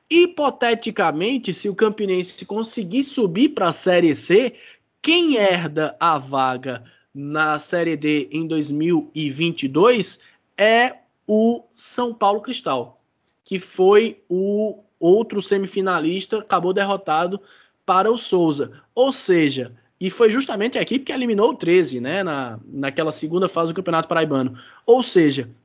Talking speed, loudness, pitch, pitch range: 130 wpm, -20 LUFS, 190 Hz, 160-225 Hz